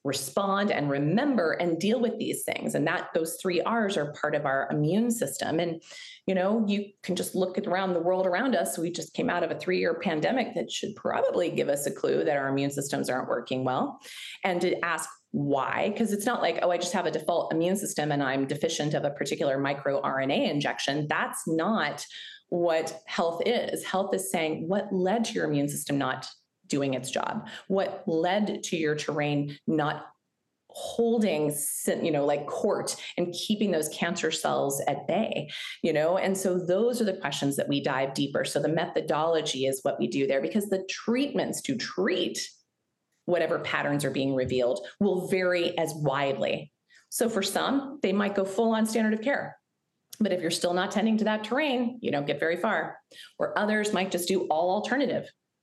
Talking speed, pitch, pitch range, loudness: 195 wpm, 175 Hz, 145-205 Hz, -28 LUFS